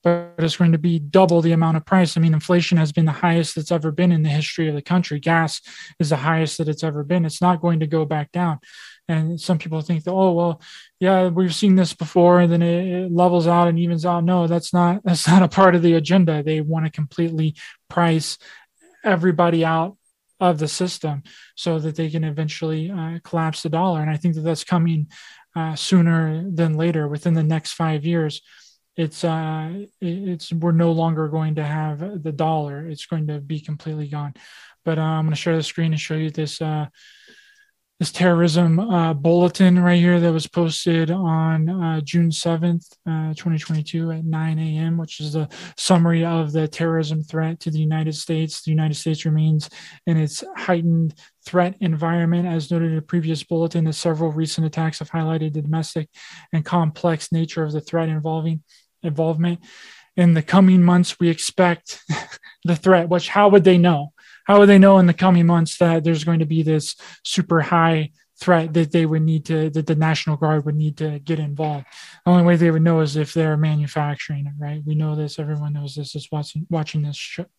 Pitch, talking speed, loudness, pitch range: 165 Hz, 205 wpm, -19 LUFS, 155-175 Hz